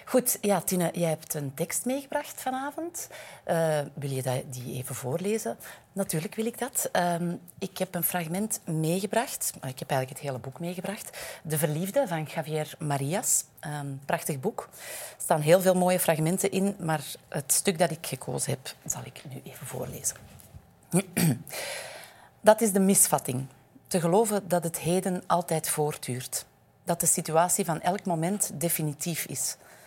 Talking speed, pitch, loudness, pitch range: 160 wpm, 170 Hz, -28 LUFS, 145-190 Hz